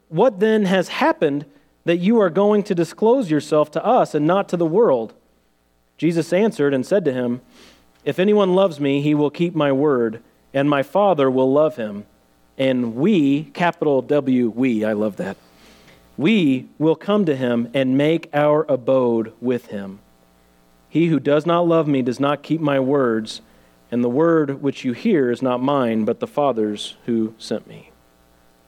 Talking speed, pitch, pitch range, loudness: 175 wpm, 140 Hz, 115-165 Hz, -19 LUFS